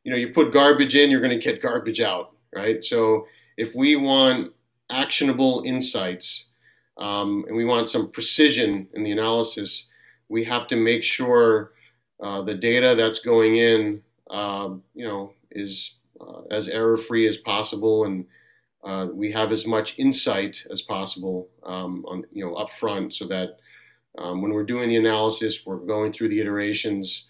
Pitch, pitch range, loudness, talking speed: 110 Hz, 100-120 Hz, -22 LUFS, 170 wpm